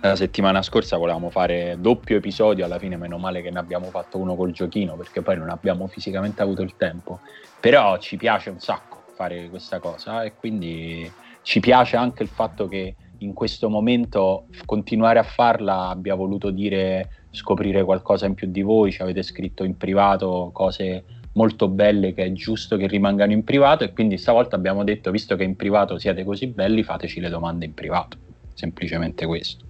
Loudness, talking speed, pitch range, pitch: -22 LUFS, 185 wpm, 90-105 Hz, 95 Hz